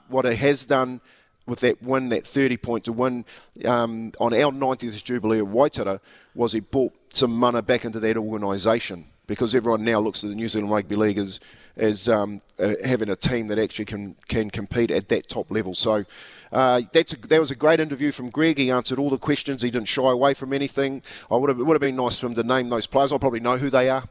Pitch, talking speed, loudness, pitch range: 120 Hz, 240 wpm, -23 LUFS, 110-135 Hz